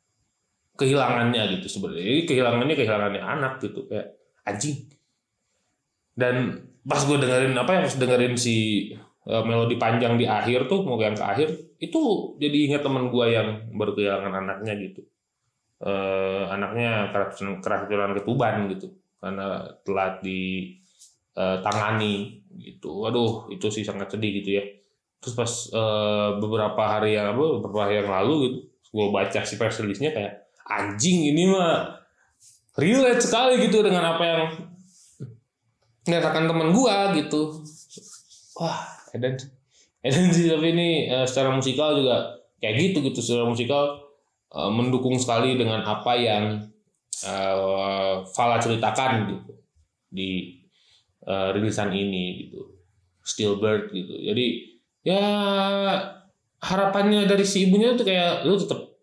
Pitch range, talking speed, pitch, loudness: 100-150 Hz, 125 wpm, 115 Hz, -24 LUFS